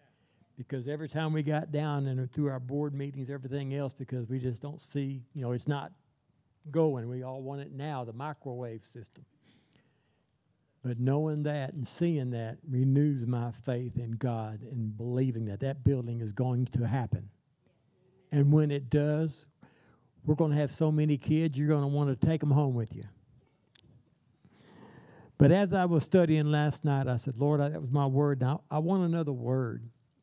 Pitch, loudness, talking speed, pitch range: 140 Hz, -31 LUFS, 185 wpm, 125-150 Hz